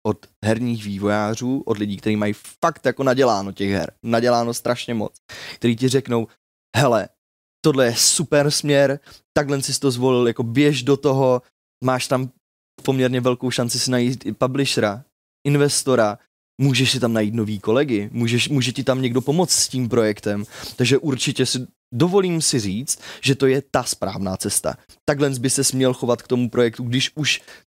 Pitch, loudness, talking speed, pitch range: 125 Hz, -20 LUFS, 170 wpm, 115-135 Hz